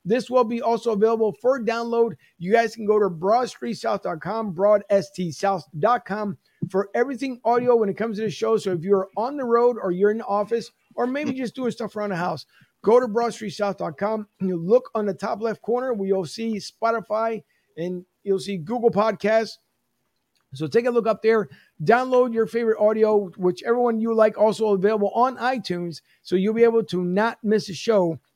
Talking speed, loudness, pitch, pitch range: 190 wpm, -23 LUFS, 215 Hz, 195-230 Hz